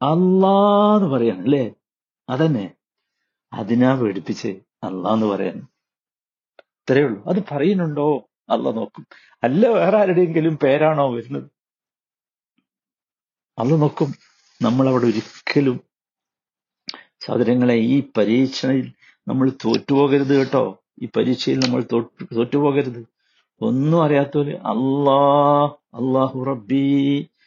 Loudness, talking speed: -19 LUFS, 85 wpm